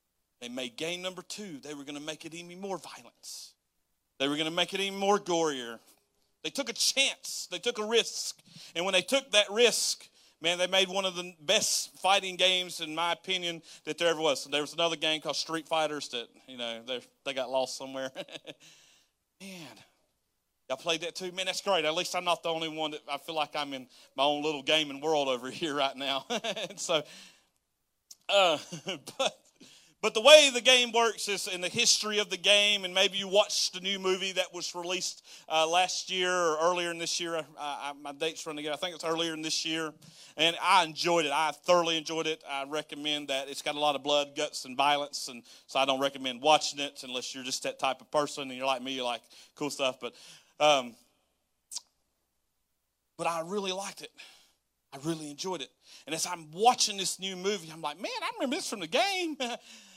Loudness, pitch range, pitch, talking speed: -29 LUFS, 145-190 Hz, 165 Hz, 215 wpm